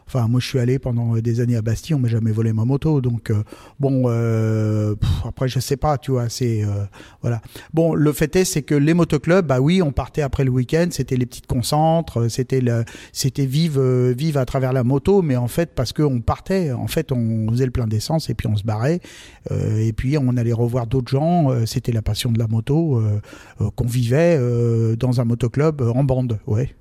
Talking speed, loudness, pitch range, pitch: 230 wpm, -20 LUFS, 115-140 Hz, 130 Hz